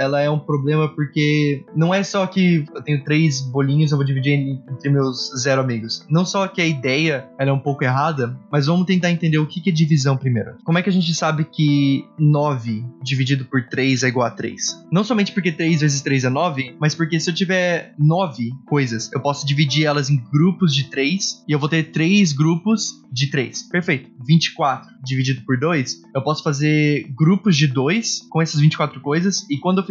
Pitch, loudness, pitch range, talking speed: 150 Hz, -19 LUFS, 135-165 Hz, 210 wpm